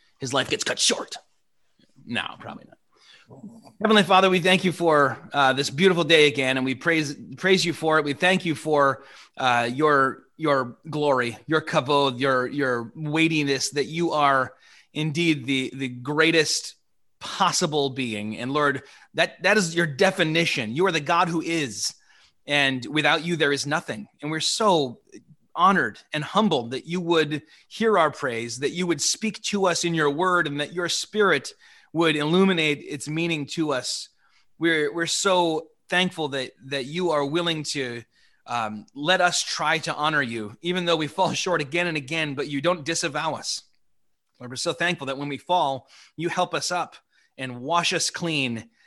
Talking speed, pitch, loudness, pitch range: 175 wpm, 155 Hz, -23 LUFS, 140-175 Hz